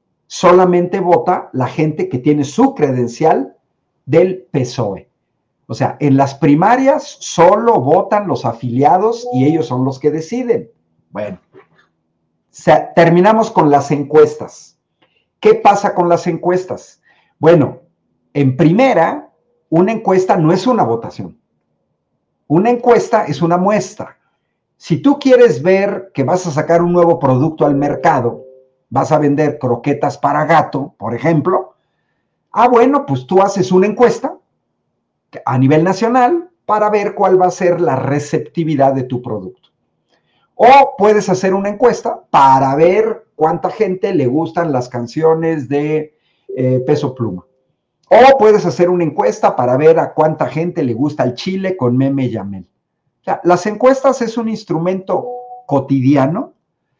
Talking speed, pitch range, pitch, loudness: 140 wpm, 140-200 Hz, 165 Hz, -13 LUFS